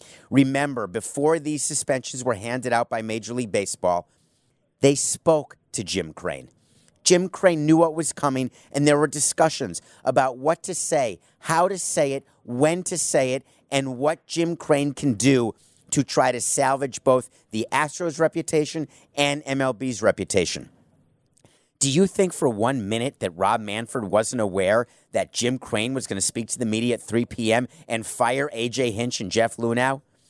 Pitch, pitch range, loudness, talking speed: 135 Hz, 120-155 Hz, -23 LUFS, 170 wpm